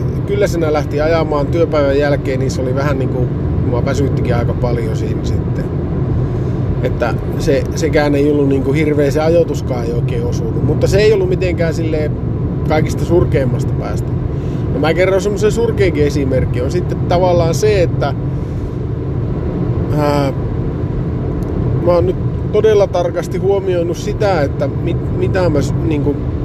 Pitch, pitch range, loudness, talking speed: 140 Hz, 130-155 Hz, -15 LUFS, 135 wpm